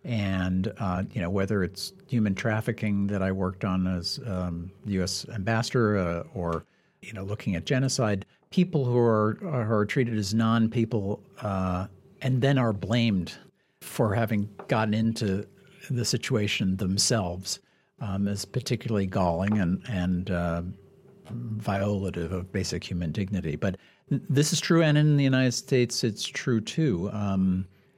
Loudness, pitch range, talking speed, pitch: -27 LUFS, 95-120 Hz, 145 wpm, 105 Hz